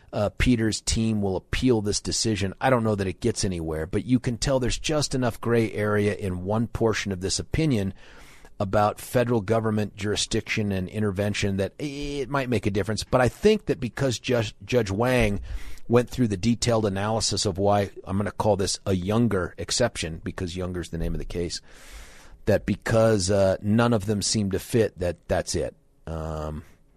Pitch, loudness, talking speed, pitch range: 105 Hz, -25 LUFS, 190 wpm, 95-120 Hz